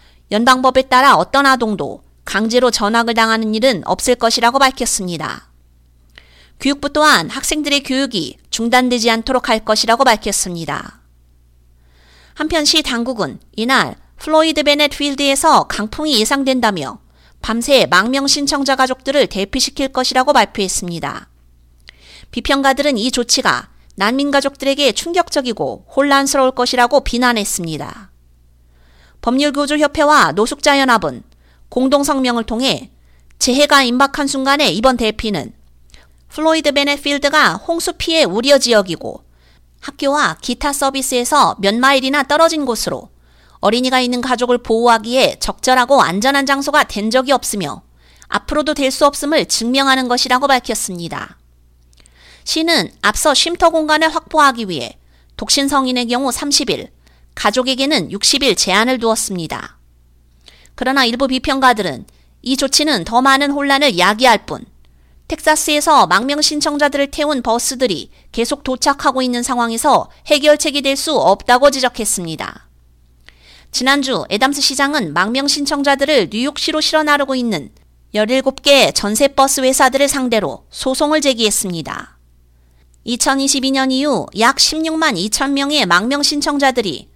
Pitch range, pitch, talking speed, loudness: 200-285 Hz, 255 Hz, 305 characters per minute, -14 LUFS